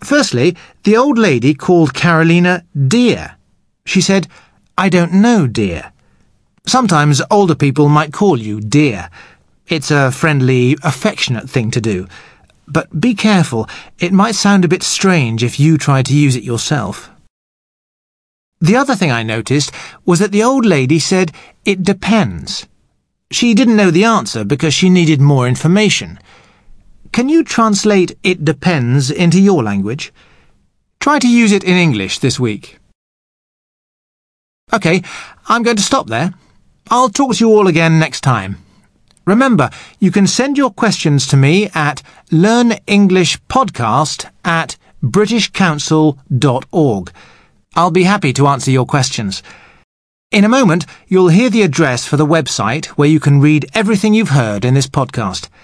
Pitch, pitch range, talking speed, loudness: 165 Hz, 135-200 Hz, 145 wpm, -12 LUFS